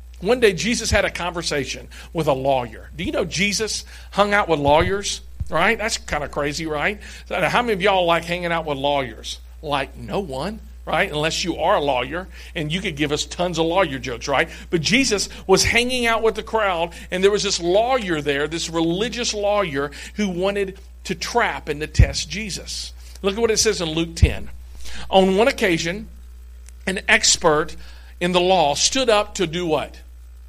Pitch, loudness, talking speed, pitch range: 170 Hz, -20 LUFS, 190 wpm, 140-205 Hz